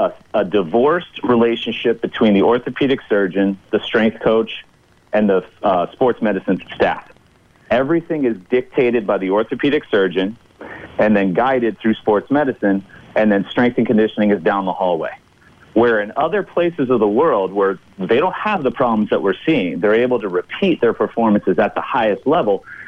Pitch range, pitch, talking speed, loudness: 100-125 Hz, 110 Hz, 170 wpm, -17 LUFS